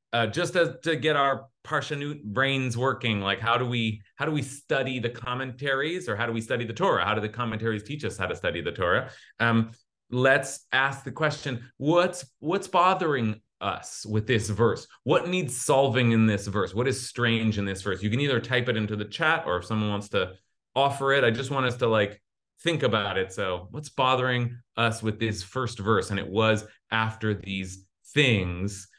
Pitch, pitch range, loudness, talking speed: 120 Hz, 110-135 Hz, -26 LUFS, 205 wpm